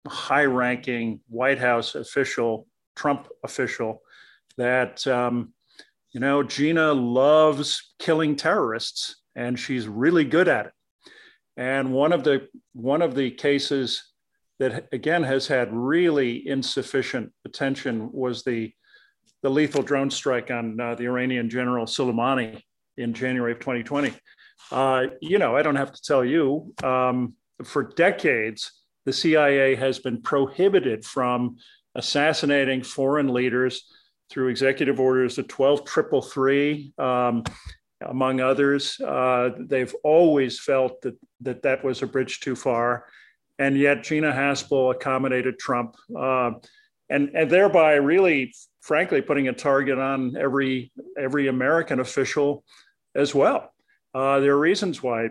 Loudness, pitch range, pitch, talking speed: -23 LUFS, 125-140 Hz, 135 Hz, 130 wpm